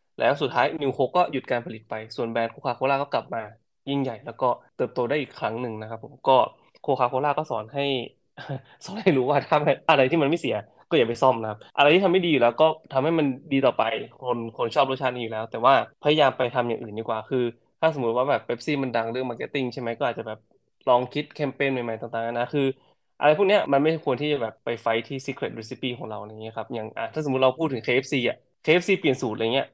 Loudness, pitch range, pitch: -24 LUFS, 115-145 Hz, 130 Hz